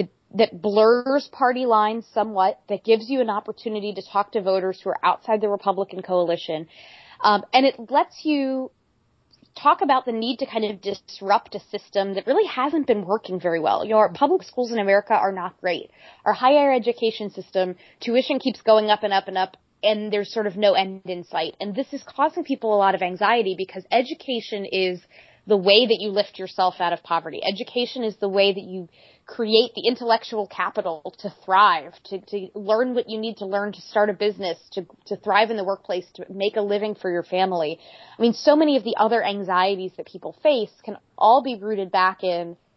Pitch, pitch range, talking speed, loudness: 210 Hz, 190-235 Hz, 205 wpm, -22 LUFS